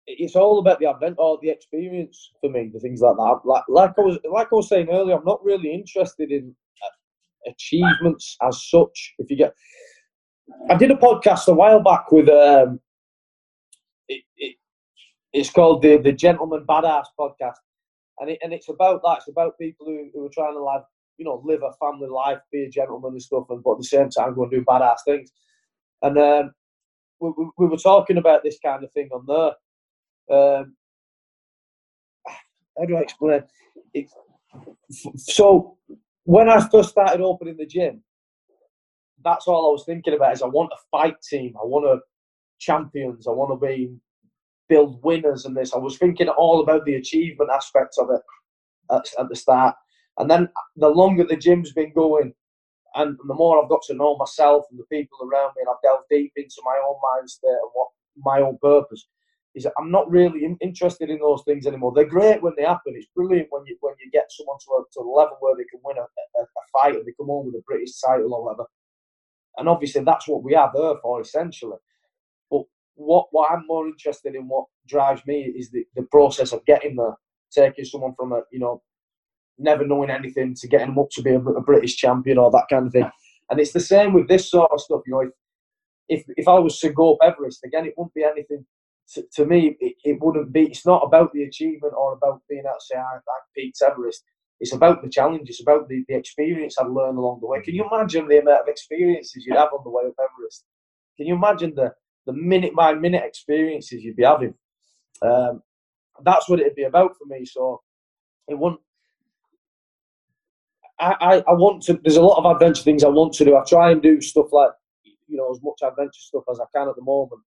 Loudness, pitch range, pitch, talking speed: -19 LUFS, 140-180 Hz, 155 Hz, 210 wpm